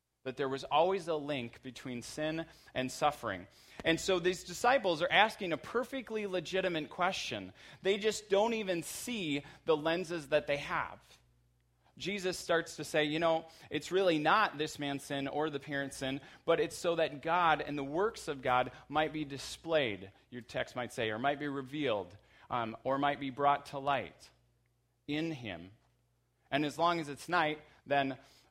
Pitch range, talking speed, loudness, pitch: 135-170 Hz, 175 wpm, -34 LUFS, 150 Hz